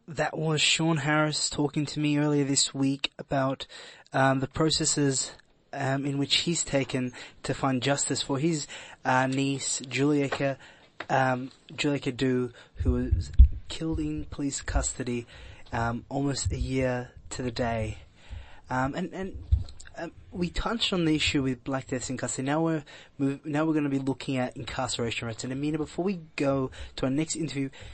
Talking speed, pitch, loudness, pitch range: 170 wpm, 135 Hz, -28 LUFS, 125-150 Hz